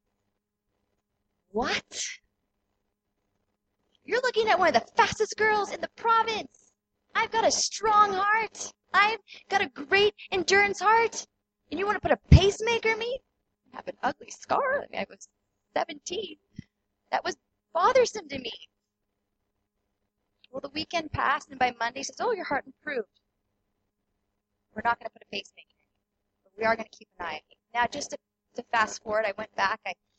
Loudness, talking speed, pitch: -27 LUFS, 175 wpm, 250 Hz